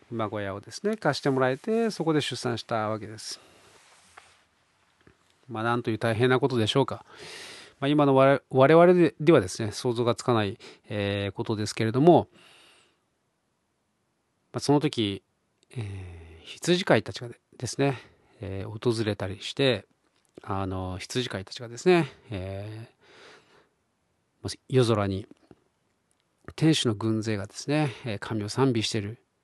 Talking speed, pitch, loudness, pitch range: 255 characters per minute, 115 Hz, -26 LUFS, 105-135 Hz